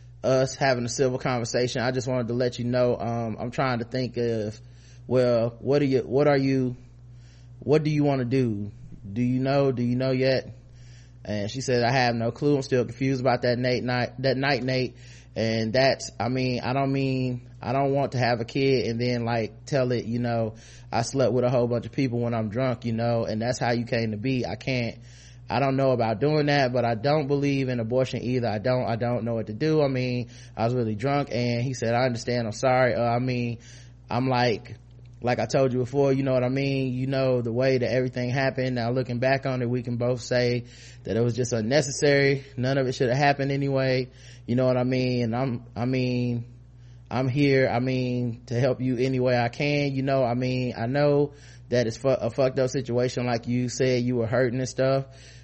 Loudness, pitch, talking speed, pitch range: -25 LUFS, 125 Hz, 235 wpm, 120-130 Hz